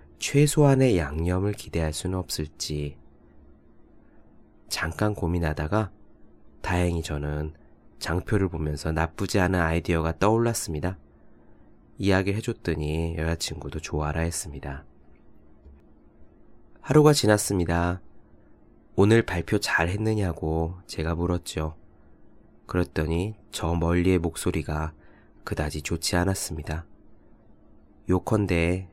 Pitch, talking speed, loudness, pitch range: 85 Hz, 240 characters per minute, -26 LUFS, 75-95 Hz